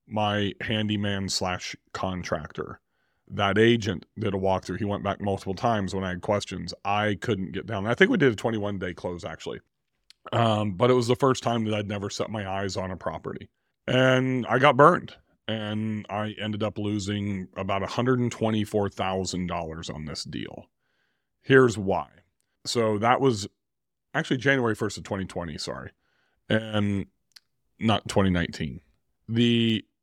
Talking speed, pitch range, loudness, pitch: 150 wpm, 95-115 Hz, -26 LUFS, 105 Hz